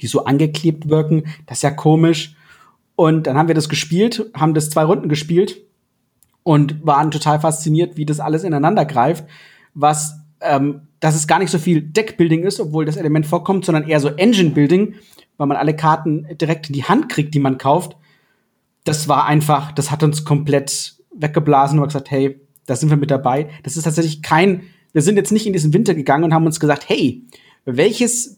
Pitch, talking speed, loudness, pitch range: 155 Hz, 200 wpm, -16 LUFS, 145-170 Hz